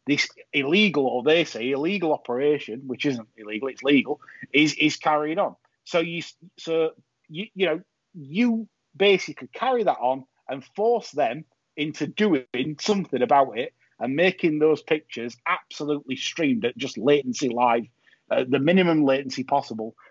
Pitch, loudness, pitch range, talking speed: 150 Hz, -24 LUFS, 130-175 Hz, 150 wpm